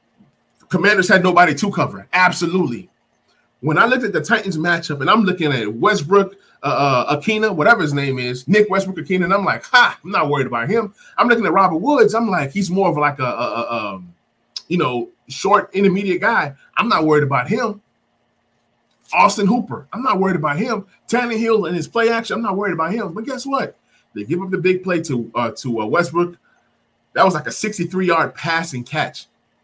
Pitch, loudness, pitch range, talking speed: 180 Hz, -17 LUFS, 145-205 Hz, 210 wpm